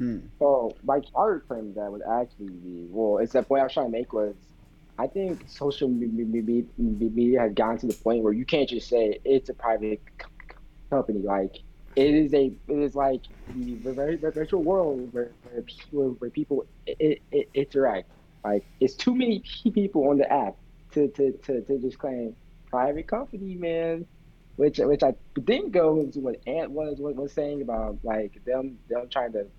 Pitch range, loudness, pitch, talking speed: 115-155 Hz, -26 LUFS, 135 Hz, 185 wpm